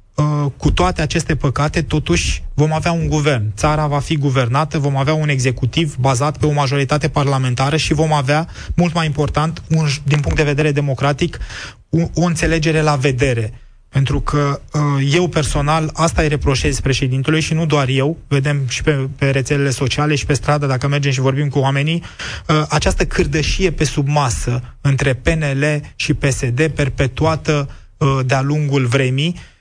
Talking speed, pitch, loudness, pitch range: 160 wpm, 145 Hz, -17 LUFS, 135-155 Hz